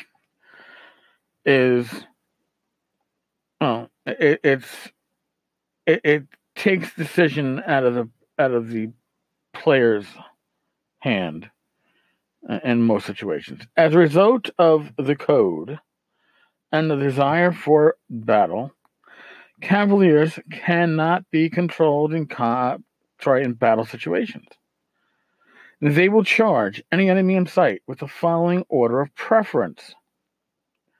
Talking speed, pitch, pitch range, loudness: 105 wpm, 155 Hz, 130-180 Hz, -20 LUFS